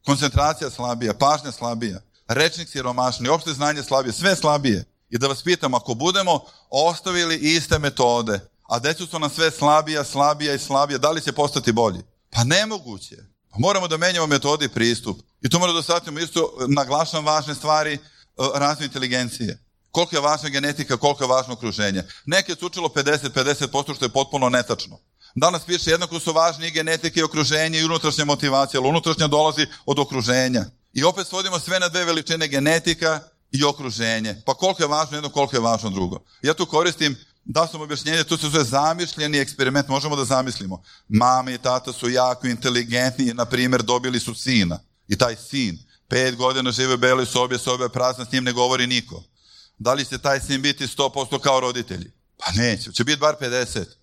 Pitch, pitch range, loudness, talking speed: 140 Hz, 125-155 Hz, -21 LUFS, 180 wpm